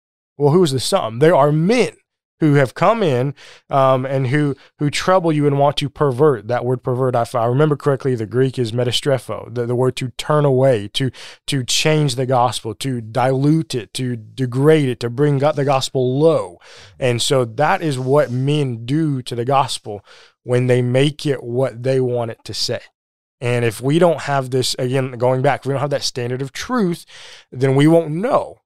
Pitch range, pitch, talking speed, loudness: 125-145 Hz, 135 Hz, 200 wpm, -18 LUFS